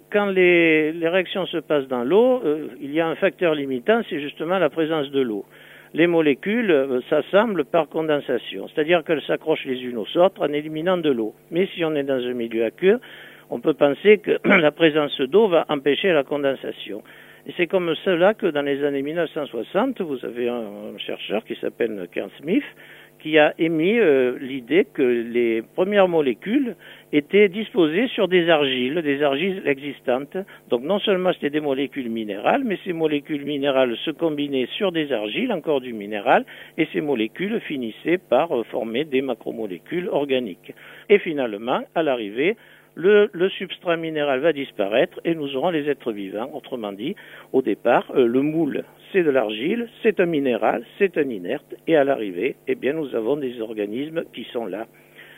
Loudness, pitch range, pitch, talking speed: -22 LUFS, 135-185 Hz, 155 Hz, 180 wpm